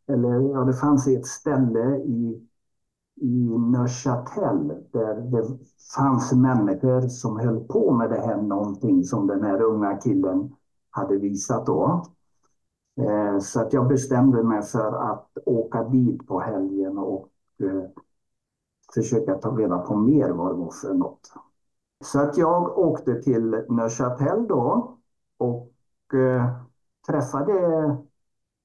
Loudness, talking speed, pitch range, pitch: -23 LUFS, 130 wpm, 110-135 Hz, 125 Hz